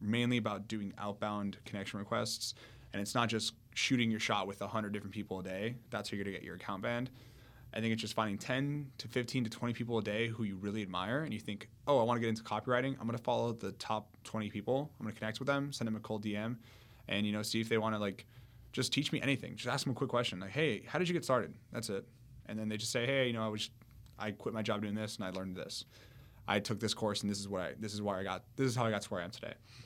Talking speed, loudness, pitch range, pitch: 295 wpm, -37 LUFS, 105-120 Hz, 110 Hz